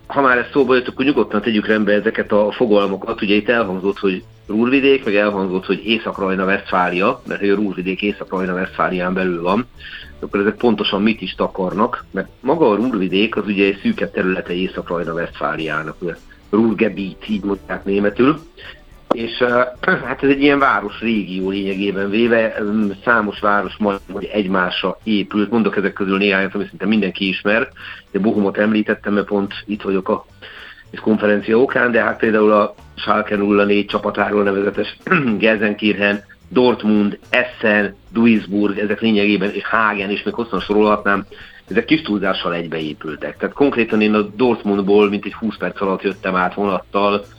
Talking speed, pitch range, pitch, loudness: 150 wpm, 100-110 Hz, 105 Hz, -17 LUFS